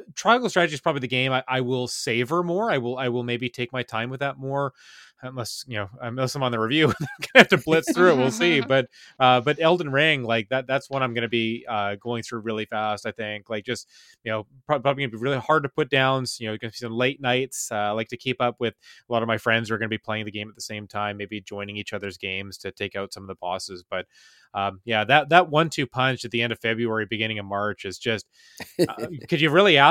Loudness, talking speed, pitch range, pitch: -24 LUFS, 275 wpm, 110-135 Hz, 120 Hz